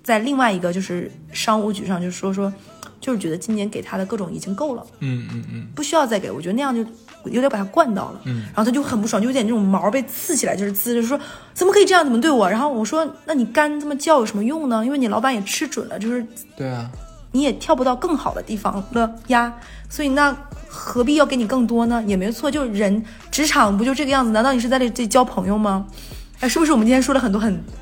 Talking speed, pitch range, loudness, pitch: 370 characters per minute, 210-275 Hz, -20 LUFS, 235 Hz